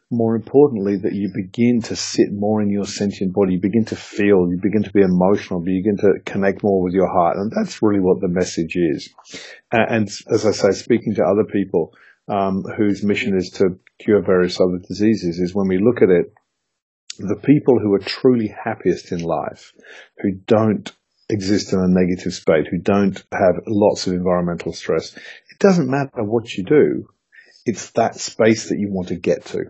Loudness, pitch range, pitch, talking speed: -18 LUFS, 95-110 Hz, 100 Hz, 195 wpm